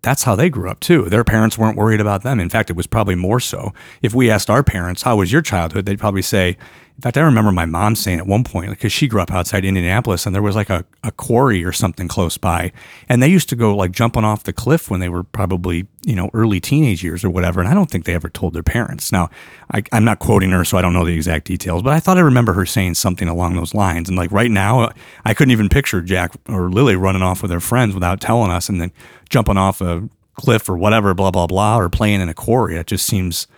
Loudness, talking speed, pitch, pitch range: -16 LUFS, 270 wpm, 100 Hz, 90-115 Hz